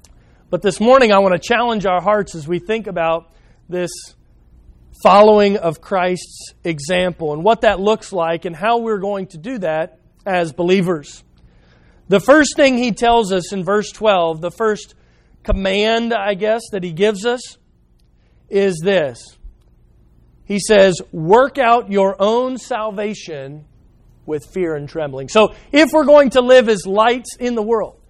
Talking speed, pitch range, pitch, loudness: 160 wpm, 165-220 Hz, 195 Hz, -16 LUFS